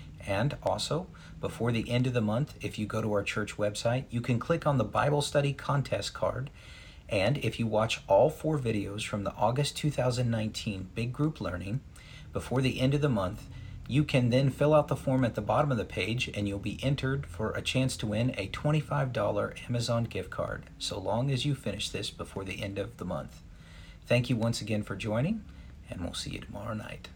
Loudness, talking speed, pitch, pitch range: -31 LUFS, 210 wpm, 115 Hz, 105-135 Hz